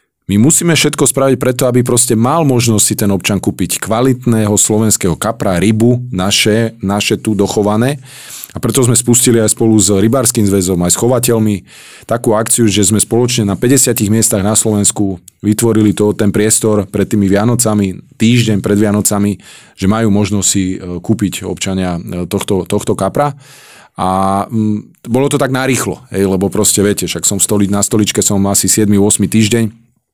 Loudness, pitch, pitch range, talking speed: -12 LUFS, 105 Hz, 100-115 Hz, 160 wpm